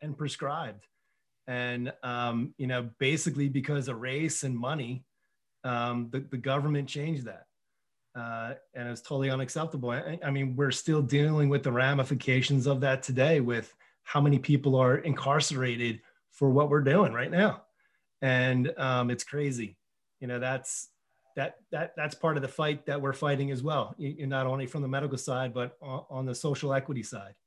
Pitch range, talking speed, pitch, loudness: 125-145 Hz, 175 wpm, 135 Hz, -30 LUFS